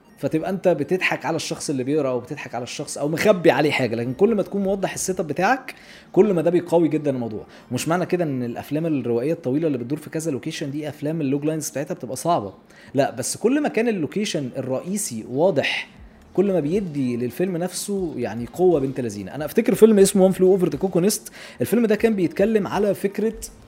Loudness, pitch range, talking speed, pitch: -22 LUFS, 140-190 Hz, 200 wpm, 165 Hz